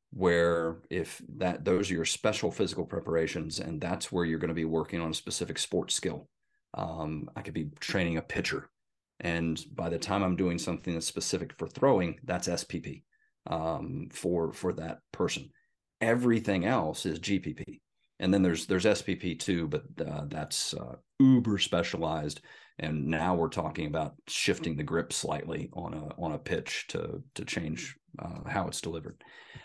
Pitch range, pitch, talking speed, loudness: 80-95 Hz, 85 Hz, 170 wpm, -31 LUFS